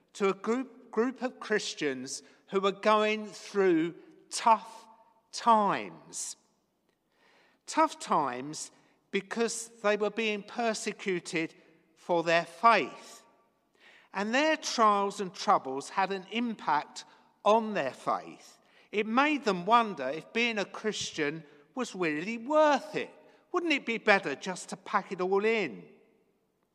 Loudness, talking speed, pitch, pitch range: -30 LUFS, 125 wpm, 215 Hz, 195-230 Hz